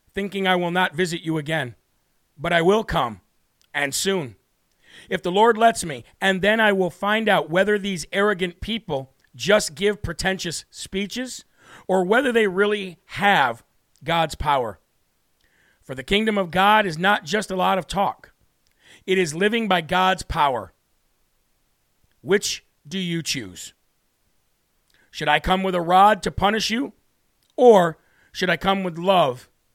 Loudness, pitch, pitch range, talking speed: -21 LUFS, 185 Hz, 160-205 Hz, 155 wpm